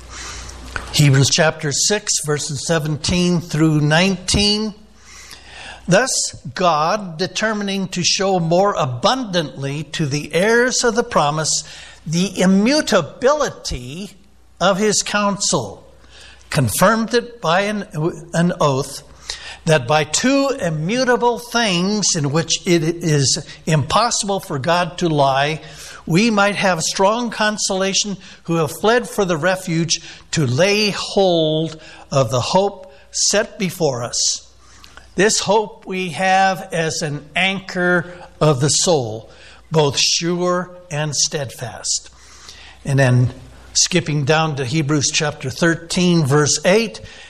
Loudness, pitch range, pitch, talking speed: -17 LUFS, 155-195 Hz, 175 Hz, 115 wpm